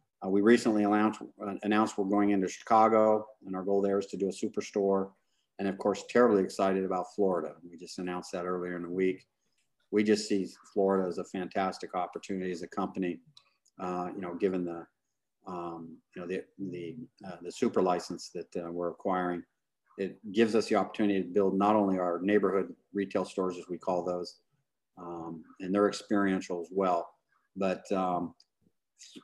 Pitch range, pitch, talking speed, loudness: 90-105 Hz, 95 Hz, 180 wpm, -31 LUFS